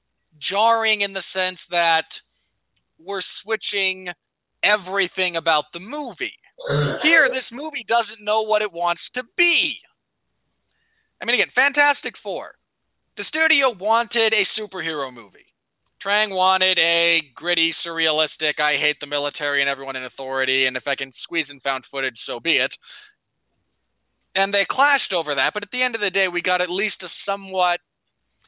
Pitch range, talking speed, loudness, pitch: 155-215 Hz, 155 wpm, -21 LUFS, 185 Hz